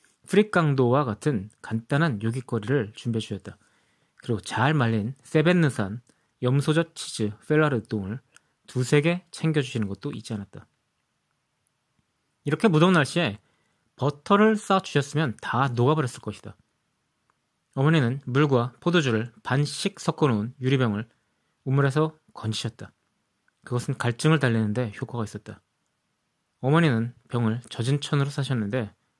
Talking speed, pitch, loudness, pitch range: 290 characters per minute, 130 Hz, -25 LUFS, 110-155 Hz